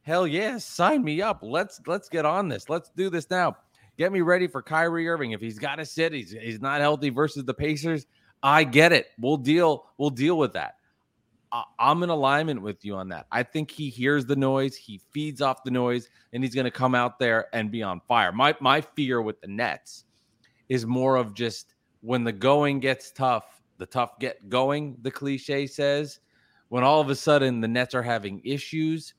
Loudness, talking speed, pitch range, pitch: -25 LUFS, 210 wpm, 120-150 Hz, 135 Hz